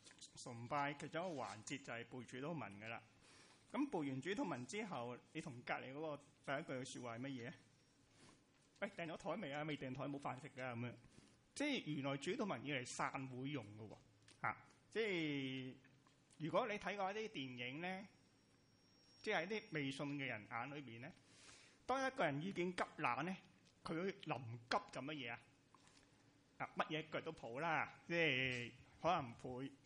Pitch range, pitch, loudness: 125-160 Hz, 140 Hz, -46 LUFS